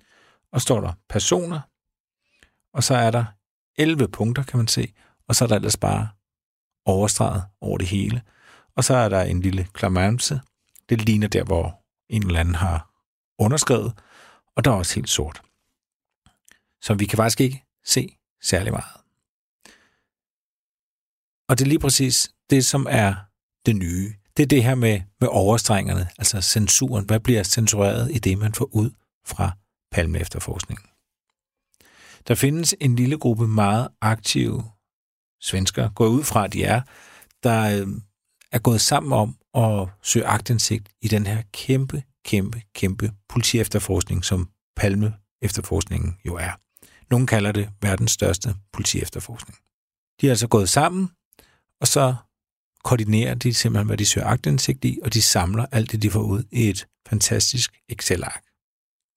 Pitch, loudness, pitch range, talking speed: 110 Hz, -21 LUFS, 100-120 Hz, 150 wpm